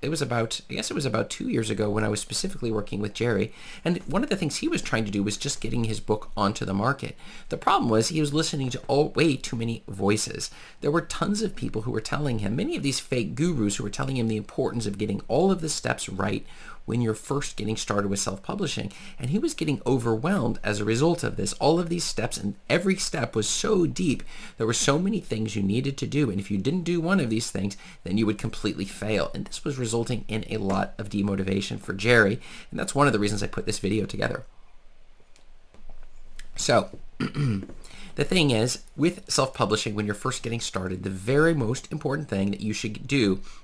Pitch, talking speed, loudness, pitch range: 115 Hz, 230 wpm, -26 LUFS, 105-145 Hz